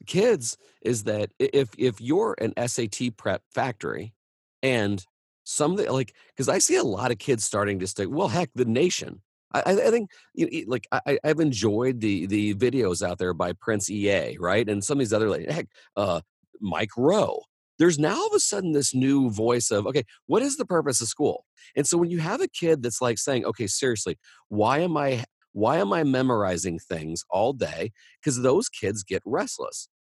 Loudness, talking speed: -25 LUFS, 200 wpm